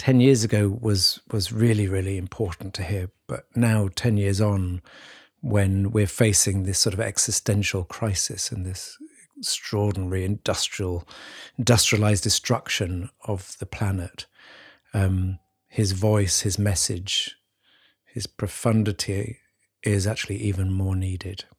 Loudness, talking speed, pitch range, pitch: -24 LUFS, 120 wpm, 95-110 Hz, 100 Hz